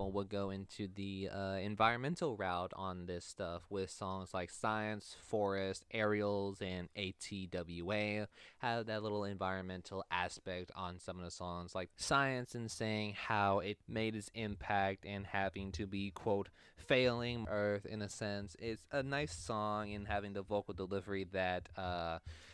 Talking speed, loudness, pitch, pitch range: 155 wpm, -40 LUFS, 100 Hz, 95-105 Hz